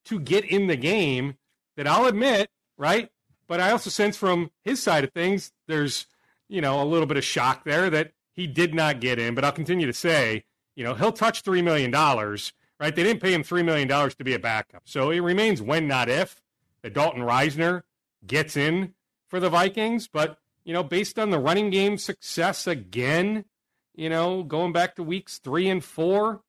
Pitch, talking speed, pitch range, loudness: 175 Hz, 200 wpm, 150-195 Hz, -24 LUFS